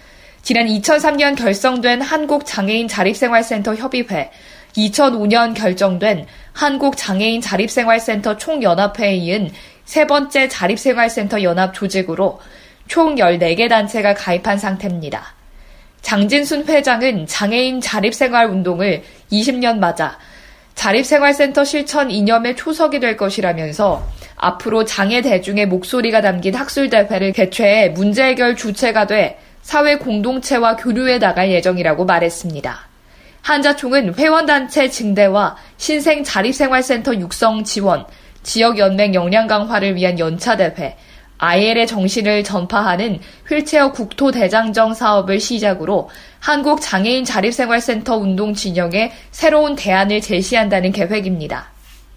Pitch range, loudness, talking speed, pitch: 195-260 Hz, -15 LUFS, 295 characters per minute, 220 Hz